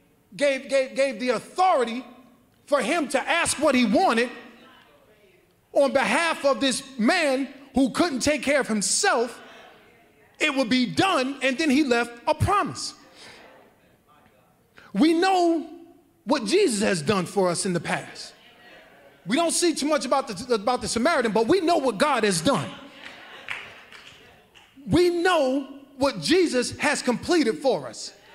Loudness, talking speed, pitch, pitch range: -23 LUFS, 145 wpm, 270 Hz, 240-310 Hz